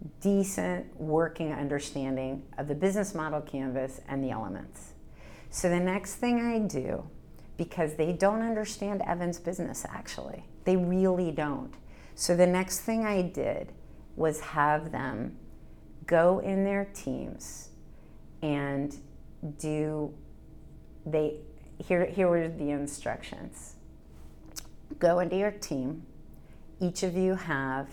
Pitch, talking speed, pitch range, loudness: 160 Hz, 120 wpm, 140-185 Hz, -30 LUFS